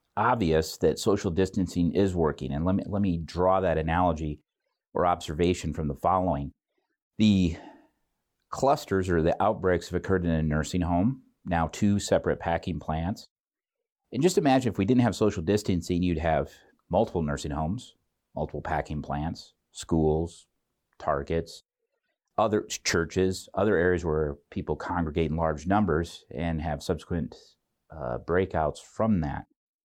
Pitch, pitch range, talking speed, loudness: 85 Hz, 80-95 Hz, 145 wpm, -27 LUFS